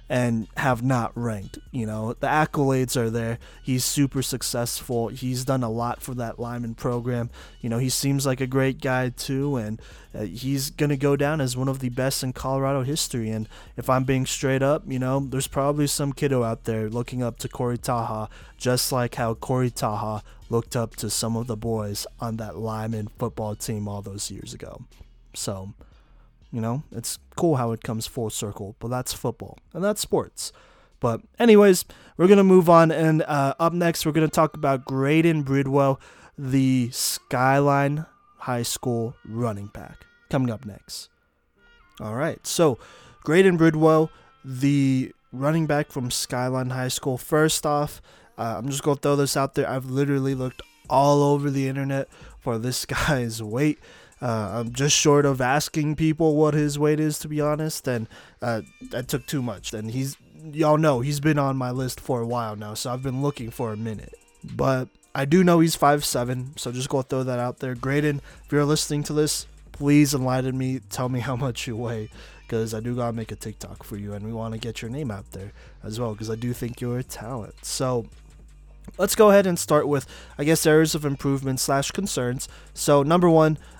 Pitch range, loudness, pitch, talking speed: 115-145 Hz, -24 LUFS, 130 Hz, 195 wpm